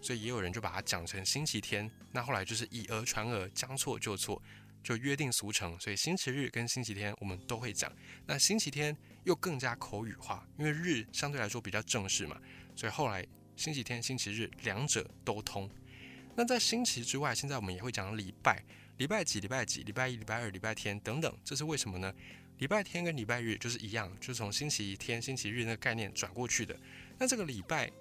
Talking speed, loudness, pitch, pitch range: 325 characters per minute, -36 LUFS, 115 Hz, 105-135 Hz